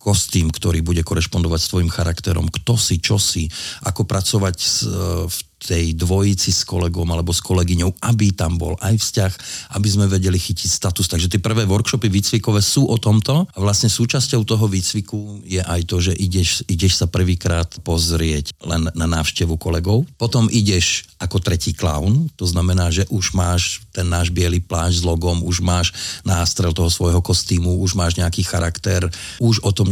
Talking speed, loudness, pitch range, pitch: 175 wpm, -18 LUFS, 85-105 Hz, 95 Hz